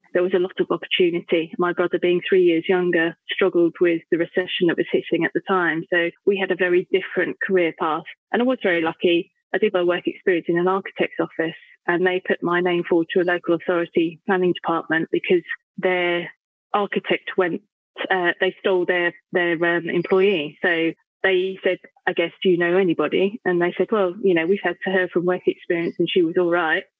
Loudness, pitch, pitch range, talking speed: -21 LUFS, 180 Hz, 175-190 Hz, 210 wpm